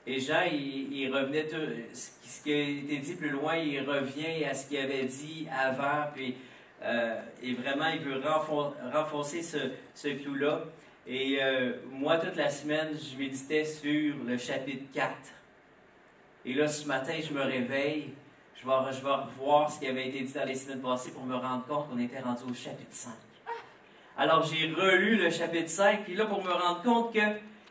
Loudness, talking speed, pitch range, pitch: -31 LUFS, 185 wpm, 130-155 Hz, 145 Hz